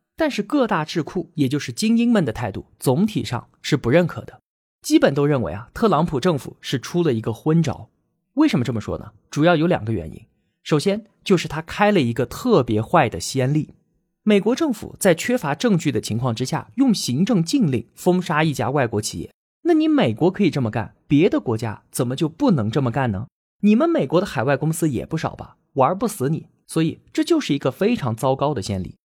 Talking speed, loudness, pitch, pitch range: 310 characters per minute, -21 LUFS, 155 Hz, 125-195 Hz